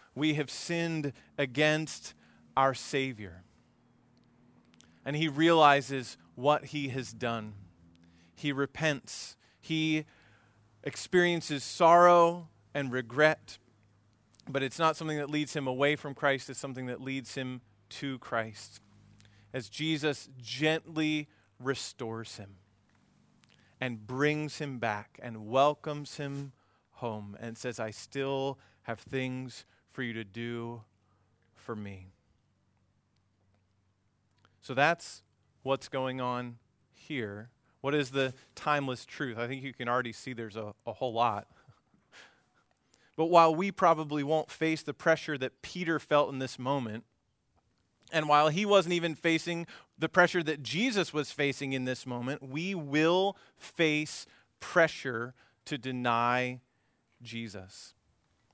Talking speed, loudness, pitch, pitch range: 125 wpm, -31 LUFS, 130 Hz, 110-150 Hz